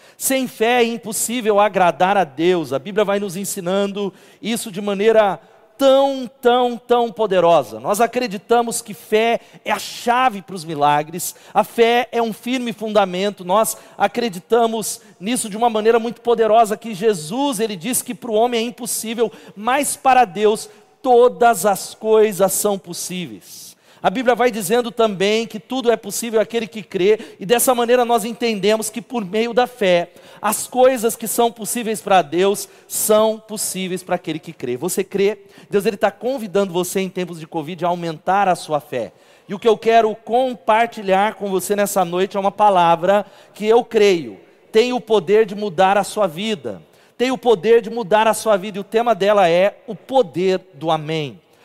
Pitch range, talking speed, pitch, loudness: 195-235 Hz, 180 wpm, 215 Hz, -18 LUFS